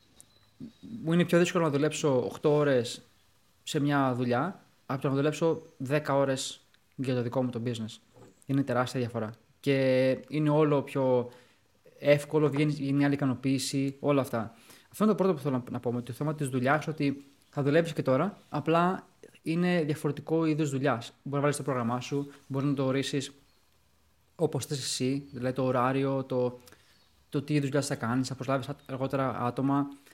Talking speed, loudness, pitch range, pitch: 175 wpm, -29 LUFS, 130-150 Hz, 140 Hz